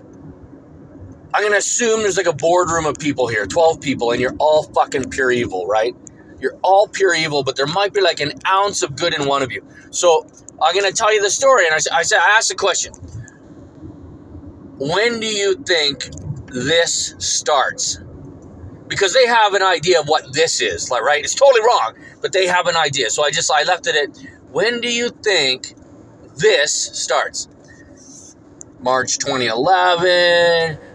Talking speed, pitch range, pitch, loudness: 180 wpm, 145-205 Hz, 175 Hz, -16 LUFS